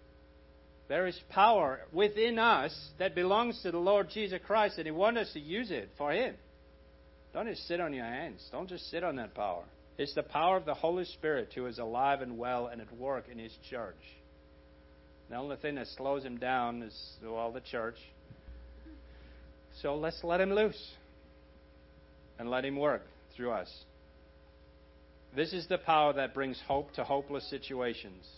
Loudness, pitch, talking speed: -34 LUFS, 120 Hz, 180 wpm